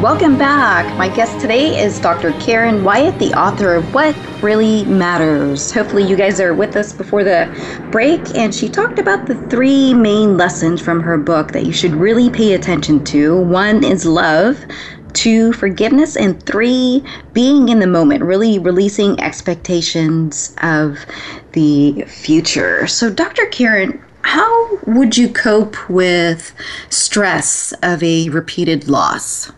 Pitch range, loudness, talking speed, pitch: 165-235 Hz, -13 LUFS, 145 wpm, 195 Hz